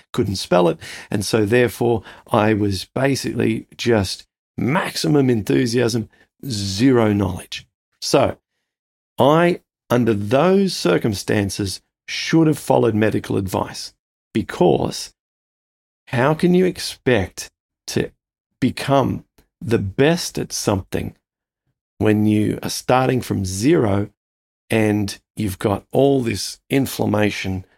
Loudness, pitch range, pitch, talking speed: -19 LUFS, 100-130 Hz, 110 Hz, 100 wpm